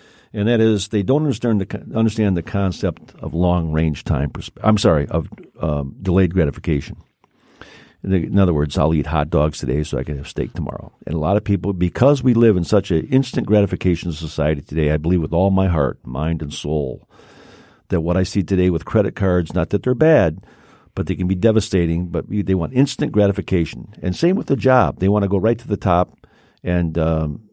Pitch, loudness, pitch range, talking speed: 90 Hz, -19 LUFS, 80-105 Hz, 205 wpm